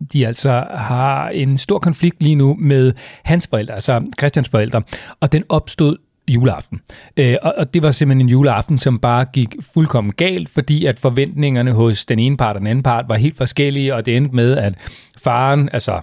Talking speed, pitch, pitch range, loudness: 185 wpm, 135 Hz, 120-145 Hz, -16 LUFS